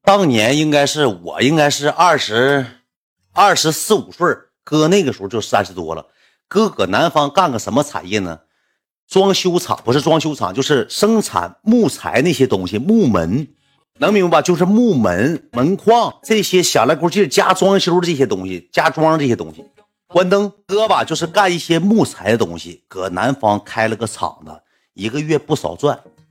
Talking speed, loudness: 270 characters per minute, -15 LUFS